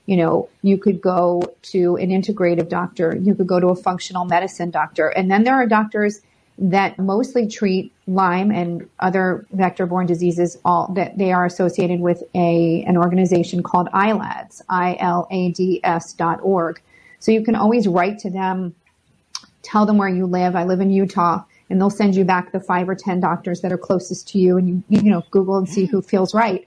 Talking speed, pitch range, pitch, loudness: 195 wpm, 175-195 Hz, 185 Hz, -18 LUFS